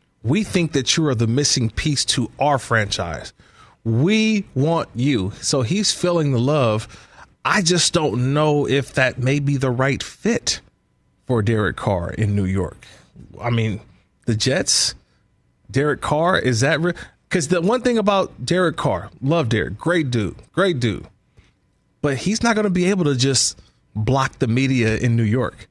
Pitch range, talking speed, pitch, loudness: 115-165 Hz, 170 wpm, 135 Hz, -19 LUFS